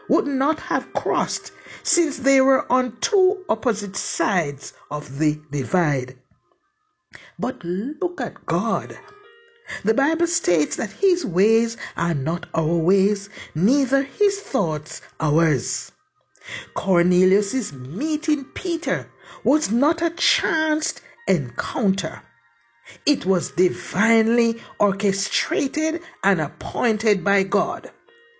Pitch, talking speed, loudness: 225 Hz, 100 wpm, -22 LUFS